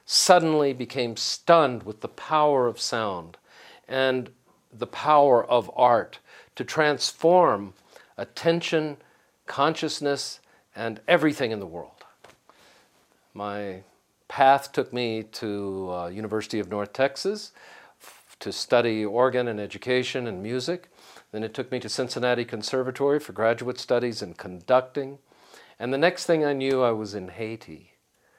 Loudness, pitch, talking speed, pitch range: -25 LUFS, 125 Hz, 130 wpm, 110-145 Hz